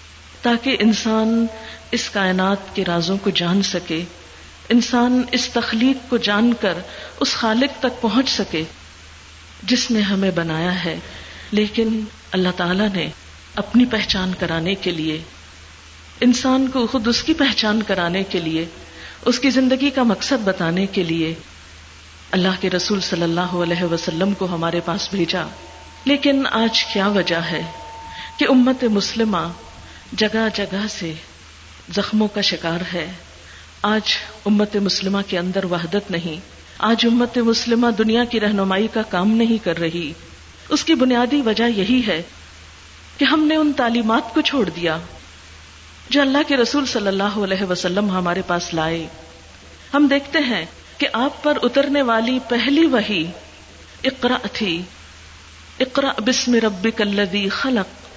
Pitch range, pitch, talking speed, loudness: 170-240 Hz, 200 Hz, 140 wpm, -19 LUFS